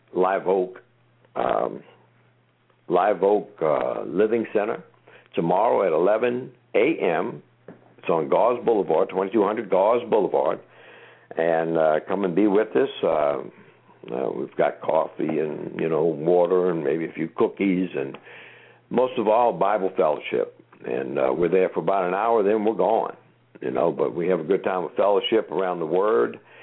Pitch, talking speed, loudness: 130 Hz, 160 wpm, -23 LUFS